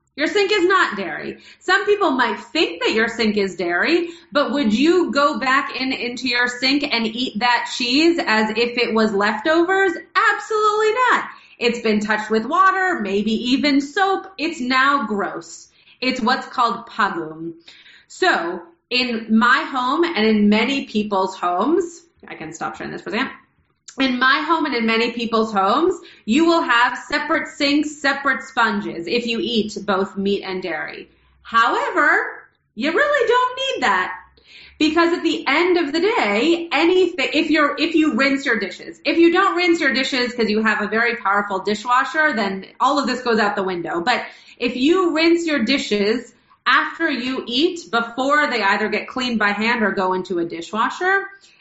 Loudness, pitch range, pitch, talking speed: -18 LUFS, 220-330 Hz, 260 Hz, 175 wpm